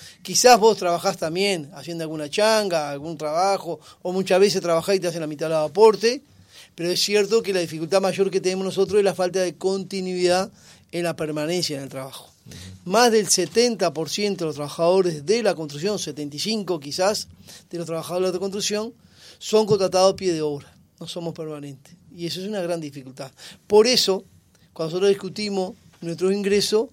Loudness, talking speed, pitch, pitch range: -22 LUFS, 180 wpm, 180 Hz, 160-200 Hz